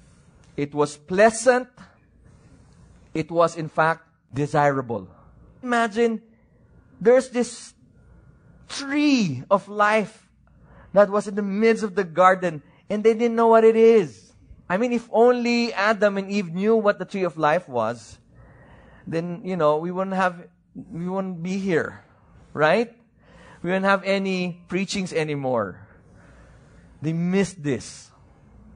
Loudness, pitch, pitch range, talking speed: -22 LUFS, 190 Hz, 160-220 Hz, 130 wpm